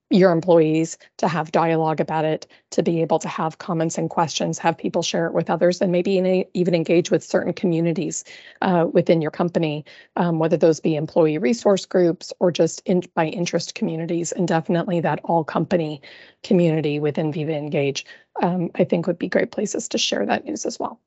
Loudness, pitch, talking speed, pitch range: -21 LUFS, 170 Hz, 195 wpm, 160-180 Hz